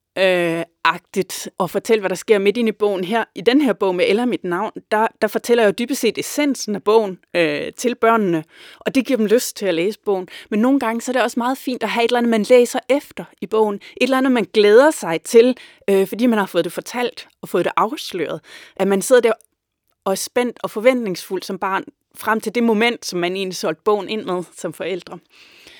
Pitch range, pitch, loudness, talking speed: 190-240 Hz, 220 Hz, -18 LUFS, 235 wpm